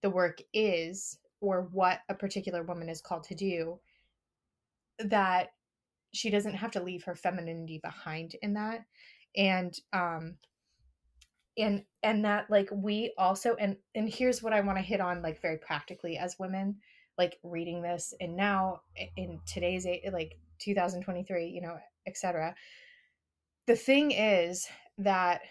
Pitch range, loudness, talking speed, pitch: 170-205 Hz, -32 LUFS, 145 wpm, 185 Hz